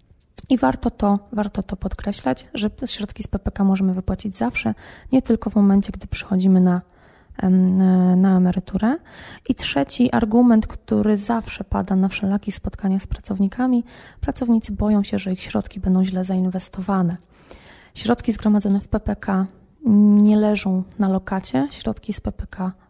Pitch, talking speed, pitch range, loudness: 200 Hz, 140 wpm, 185-215 Hz, -20 LUFS